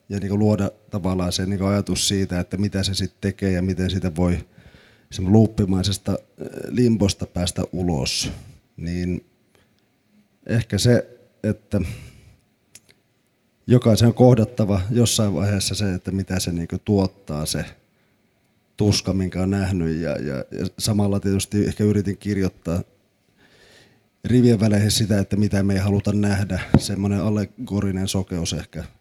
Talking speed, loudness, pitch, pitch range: 120 wpm, -21 LUFS, 100 Hz, 95-105 Hz